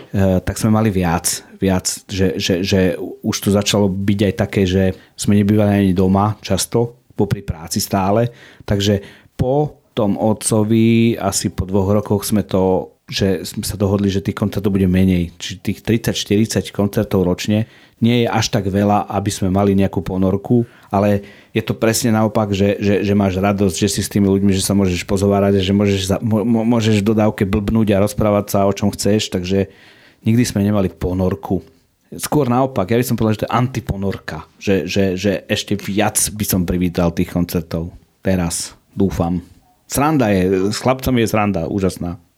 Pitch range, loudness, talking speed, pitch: 95-110 Hz, -17 LUFS, 175 wpm, 100 Hz